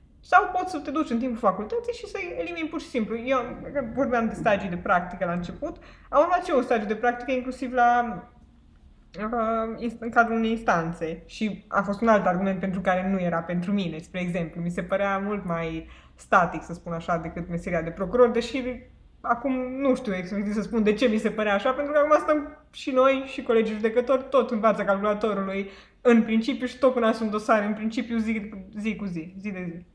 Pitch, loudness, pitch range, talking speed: 220 Hz, -25 LUFS, 185-255 Hz, 210 wpm